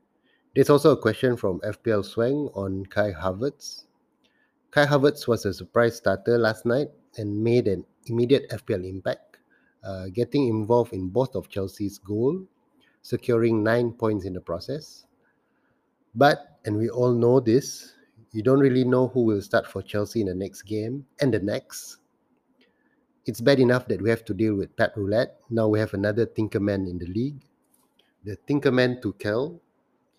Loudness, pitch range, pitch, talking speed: -24 LUFS, 105-135 Hz, 115 Hz, 170 wpm